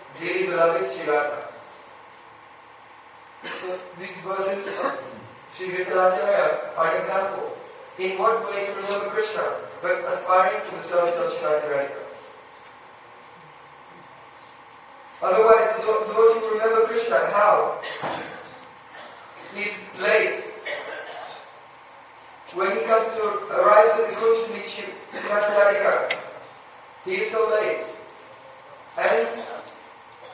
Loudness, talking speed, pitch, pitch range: -23 LUFS, 100 wpm, 210 Hz, 185-230 Hz